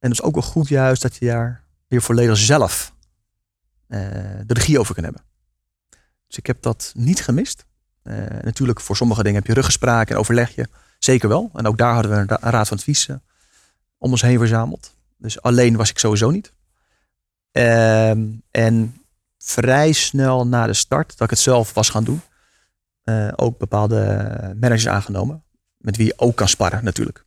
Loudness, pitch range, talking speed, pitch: -18 LUFS, 105-125 Hz, 185 wpm, 115 Hz